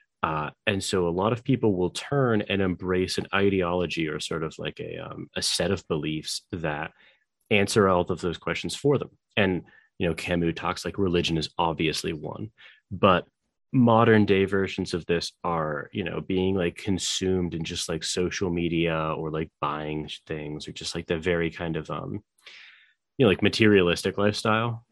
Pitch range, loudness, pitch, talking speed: 85-100 Hz, -26 LUFS, 90 Hz, 180 wpm